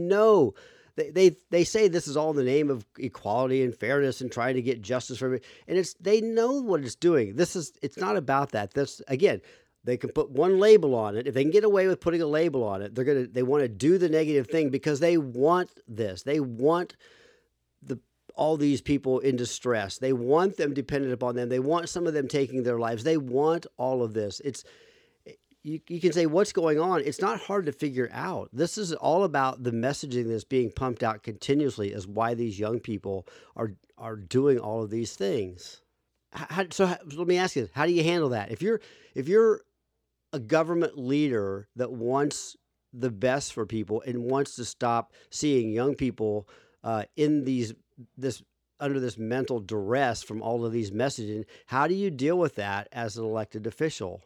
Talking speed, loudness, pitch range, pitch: 210 wpm, -27 LUFS, 115-170 Hz, 135 Hz